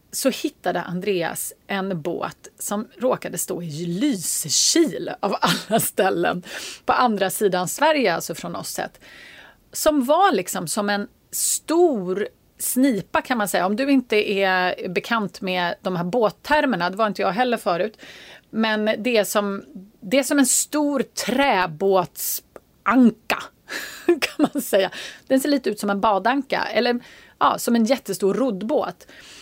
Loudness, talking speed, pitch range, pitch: -21 LUFS, 145 wpm, 190-265 Hz, 215 Hz